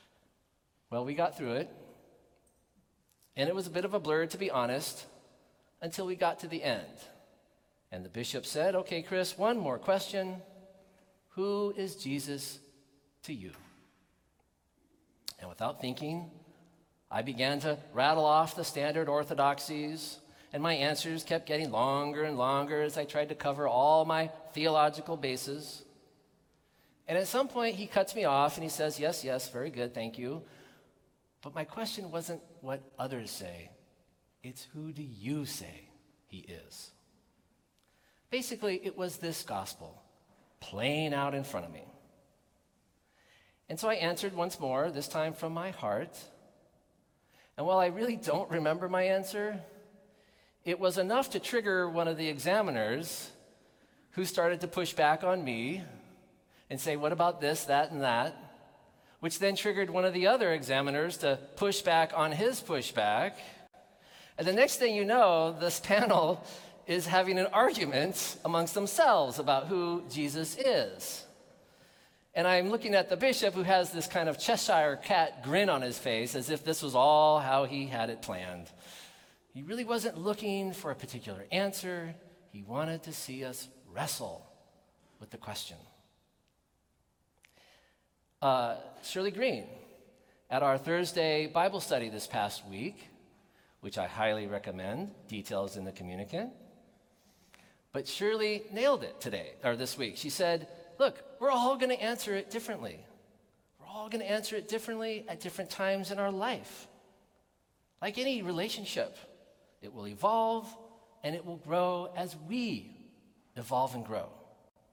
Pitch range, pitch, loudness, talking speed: 140-195 Hz, 165 Hz, -32 LUFS, 150 wpm